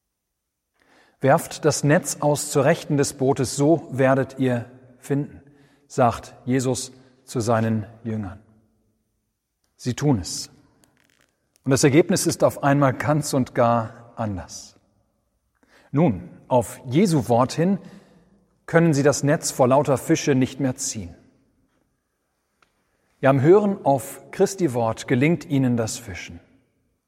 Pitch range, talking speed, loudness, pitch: 115-145 Hz, 120 wpm, -21 LUFS, 130 Hz